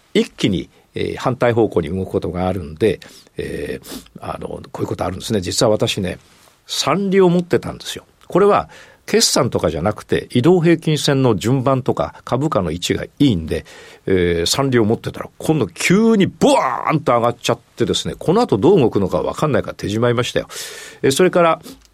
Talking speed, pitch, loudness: 370 characters per minute, 125 Hz, -17 LUFS